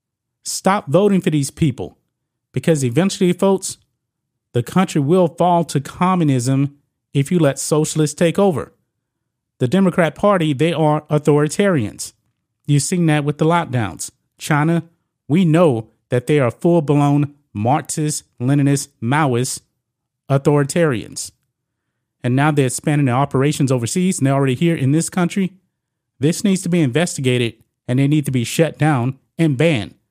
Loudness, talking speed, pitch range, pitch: -17 LUFS, 145 wpm, 130-165 Hz, 150 Hz